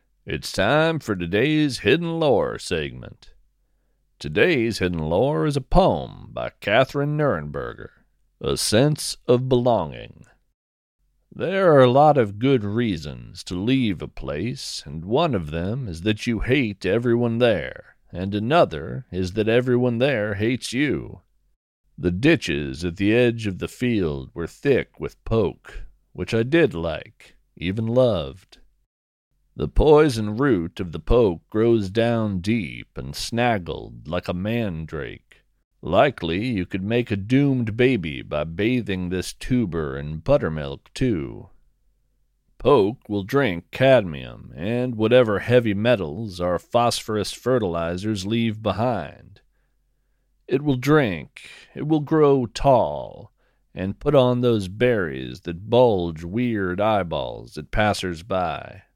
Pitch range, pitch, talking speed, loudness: 90-125 Hz, 110 Hz, 130 wpm, -22 LUFS